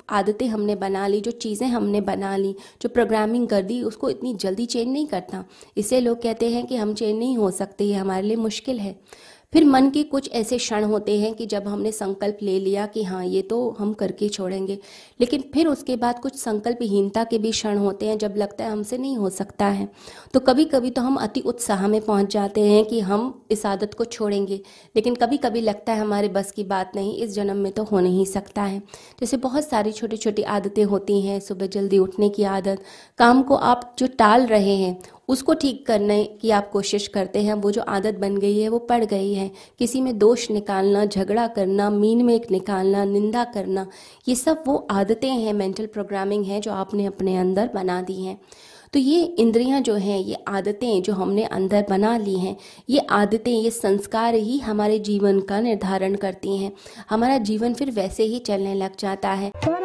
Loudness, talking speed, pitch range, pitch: -22 LUFS, 205 wpm, 200-235 Hz, 210 Hz